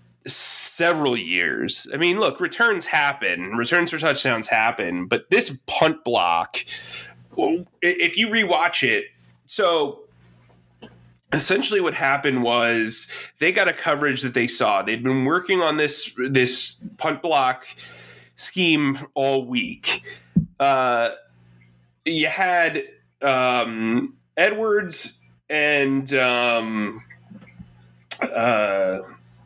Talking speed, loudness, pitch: 105 wpm, -20 LUFS, 125 Hz